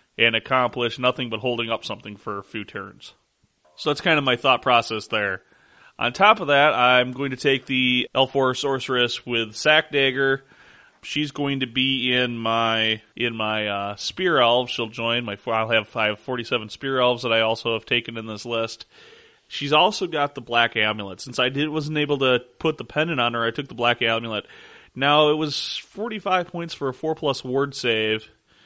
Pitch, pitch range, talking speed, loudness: 125 Hz, 115-145 Hz, 195 wpm, -22 LUFS